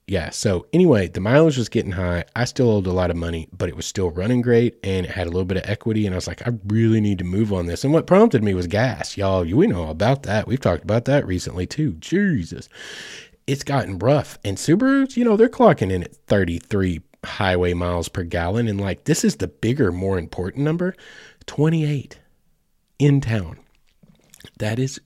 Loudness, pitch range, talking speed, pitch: -20 LUFS, 90-135 Hz, 210 wpm, 105 Hz